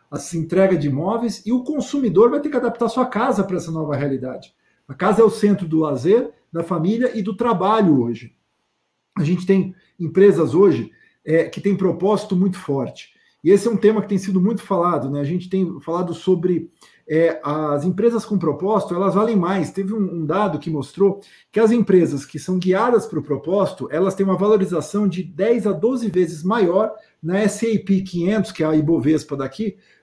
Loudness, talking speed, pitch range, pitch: -19 LUFS, 195 wpm, 165-210 Hz, 190 Hz